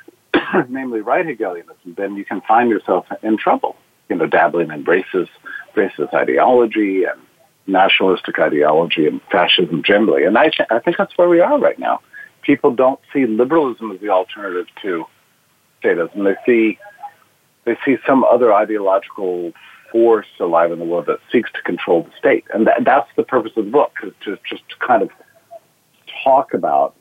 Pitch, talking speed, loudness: 120 Hz, 170 wpm, -16 LUFS